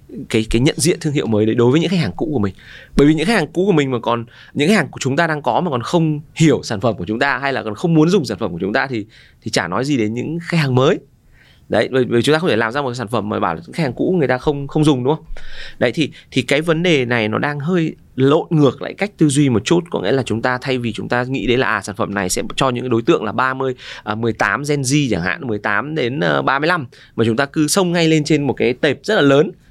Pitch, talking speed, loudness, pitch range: 135 Hz, 310 wpm, -17 LUFS, 115-155 Hz